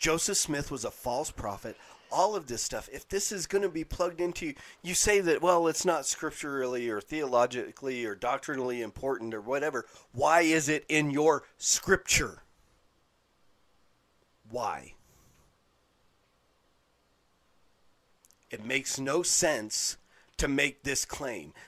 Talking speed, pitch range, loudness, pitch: 135 wpm, 130-170 Hz, -29 LUFS, 150 Hz